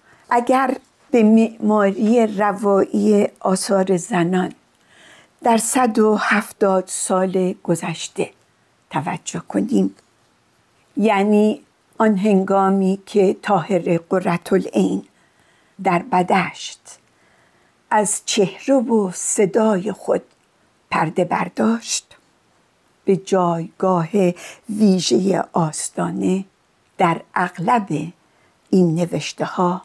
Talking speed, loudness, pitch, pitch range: 80 wpm, -19 LUFS, 195 Hz, 180-215 Hz